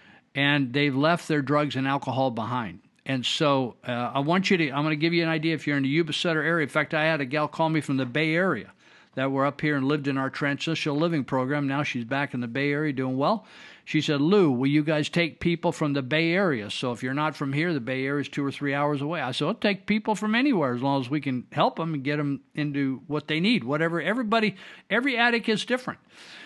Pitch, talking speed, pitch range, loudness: 150 Hz, 255 wpm, 140-165 Hz, -25 LUFS